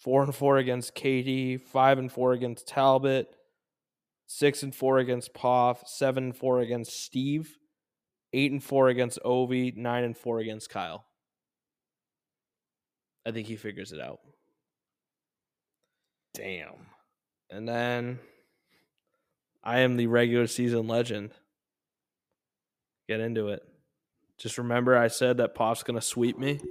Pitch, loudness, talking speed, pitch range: 125 Hz, -28 LUFS, 130 wpm, 120-130 Hz